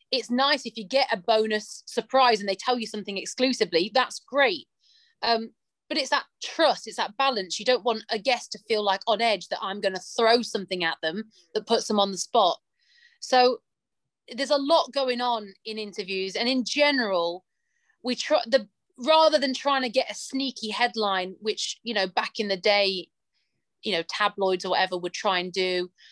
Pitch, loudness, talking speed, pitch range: 225 Hz, -25 LUFS, 200 wpm, 200-265 Hz